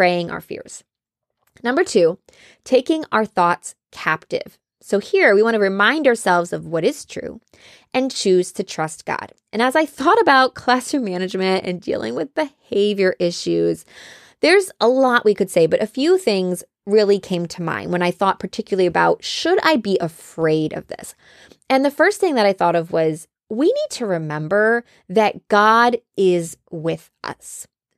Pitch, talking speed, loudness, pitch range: 205 Hz, 170 wpm, -18 LUFS, 180-260 Hz